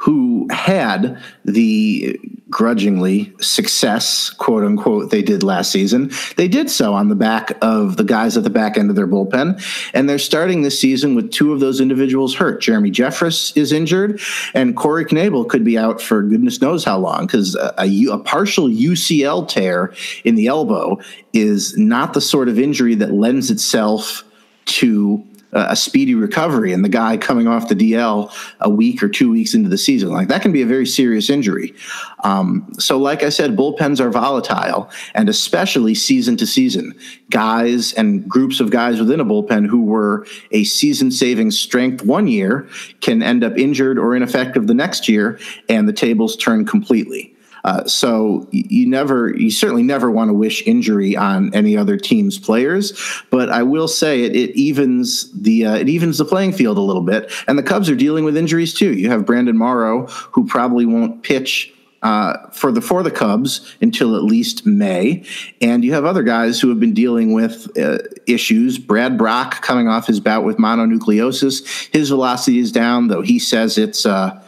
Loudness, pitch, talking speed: -15 LUFS, 200 Hz, 185 wpm